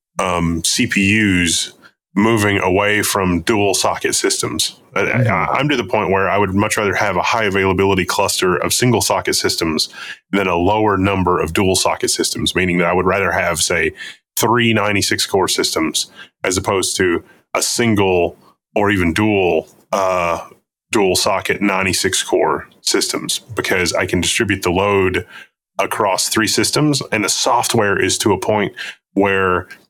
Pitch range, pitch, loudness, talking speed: 90-105 Hz, 95 Hz, -16 LUFS, 155 wpm